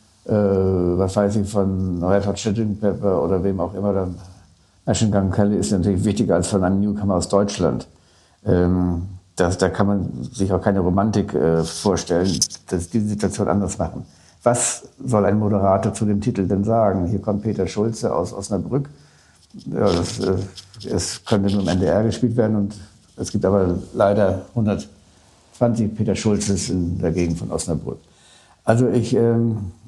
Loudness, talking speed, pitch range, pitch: -20 LUFS, 160 wpm, 90-105 Hz, 100 Hz